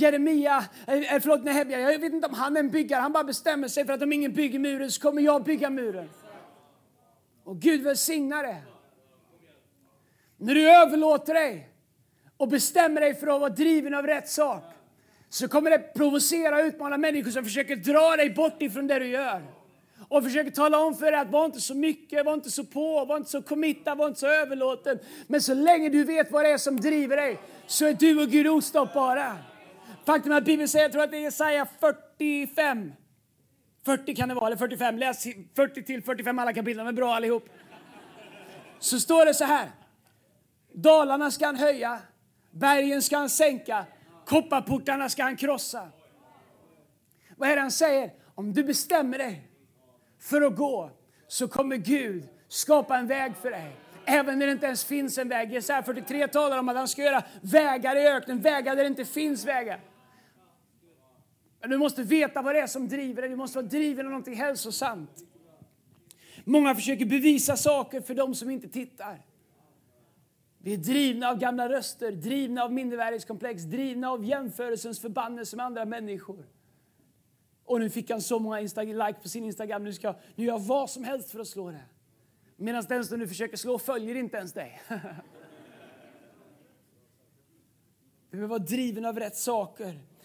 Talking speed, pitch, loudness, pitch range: 175 wpm, 265 Hz, -26 LUFS, 225-290 Hz